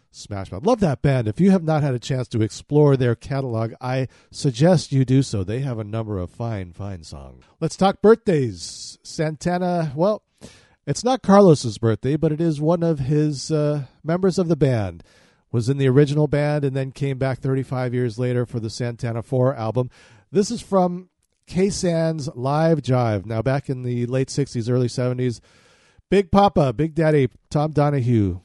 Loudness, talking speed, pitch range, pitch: -21 LUFS, 185 wpm, 120-160 Hz, 135 Hz